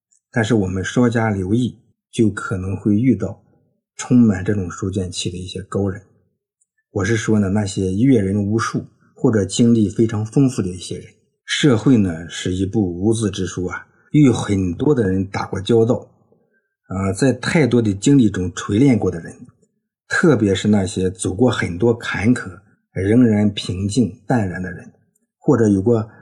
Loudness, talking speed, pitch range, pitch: -18 LUFS, 240 characters per minute, 95-120 Hz, 110 Hz